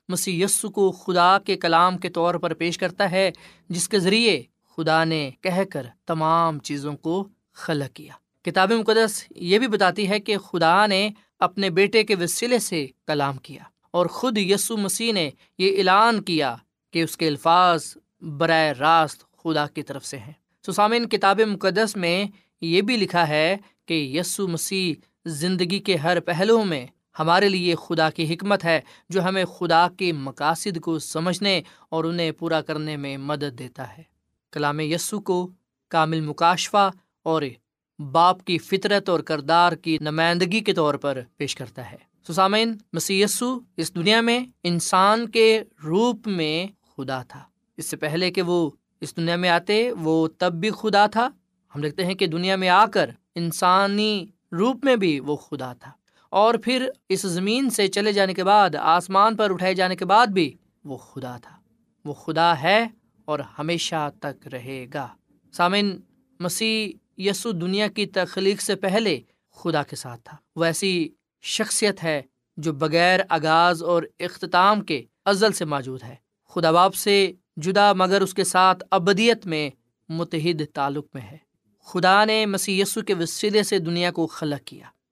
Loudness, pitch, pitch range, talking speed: -22 LUFS, 175 Hz, 160-200 Hz, 165 wpm